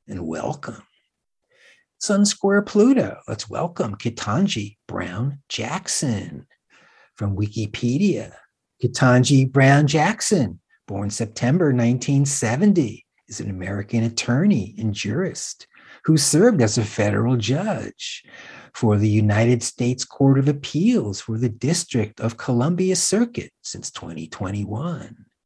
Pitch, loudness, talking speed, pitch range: 125 Hz, -21 LUFS, 105 wpm, 110-160 Hz